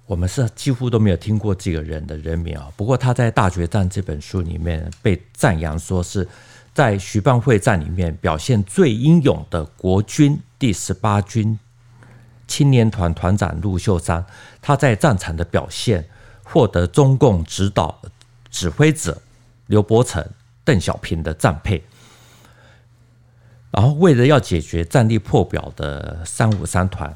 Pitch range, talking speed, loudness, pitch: 90-120 Hz, 225 characters per minute, -18 LUFS, 105 Hz